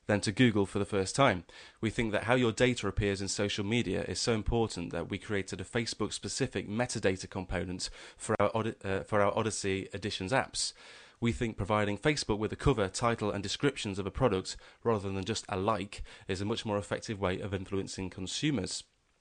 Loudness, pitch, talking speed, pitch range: -32 LUFS, 105 Hz, 195 wpm, 95-115 Hz